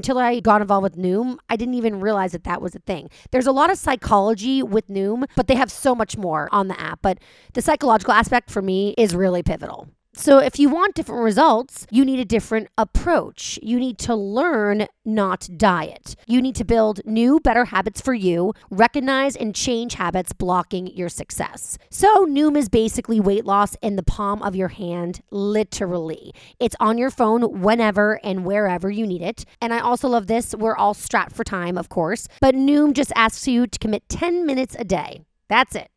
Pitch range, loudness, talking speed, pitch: 200-255 Hz, -20 LUFS, 200 wpm, 220 Hz